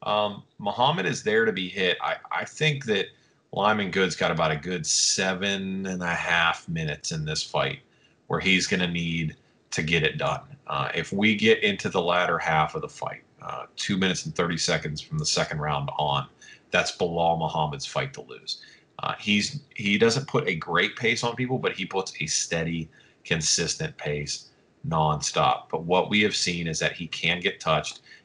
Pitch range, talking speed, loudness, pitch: 85-120 Hz, 195 wpm, -25 LUFS, 95 Hz